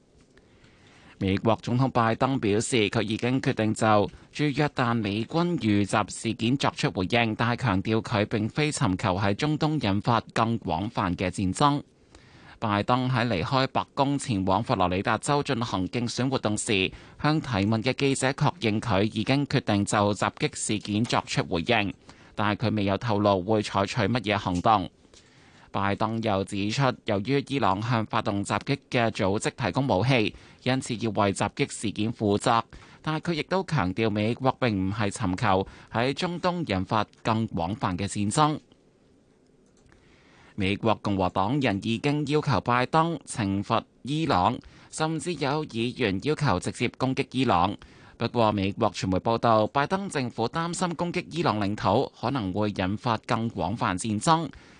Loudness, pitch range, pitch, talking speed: -26 LUFS, 100-135 Hz, 115 Hz, 240 characters per minute